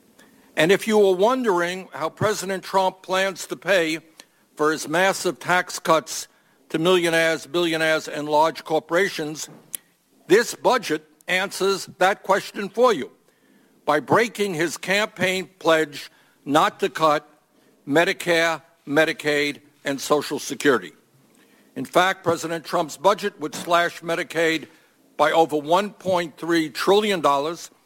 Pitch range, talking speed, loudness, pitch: 155-190 Hz, 120 wpm, -22 LUFS, 170 Hz